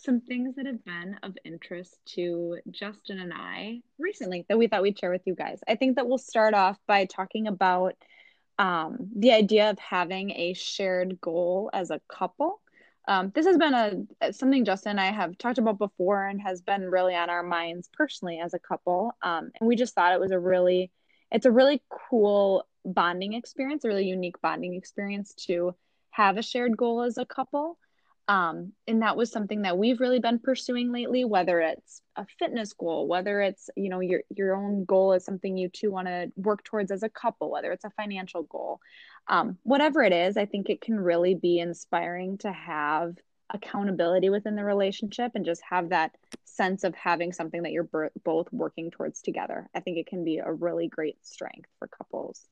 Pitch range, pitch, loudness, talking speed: 180-230 Hz, 195 Hz, -27 LUFS, 200 wpm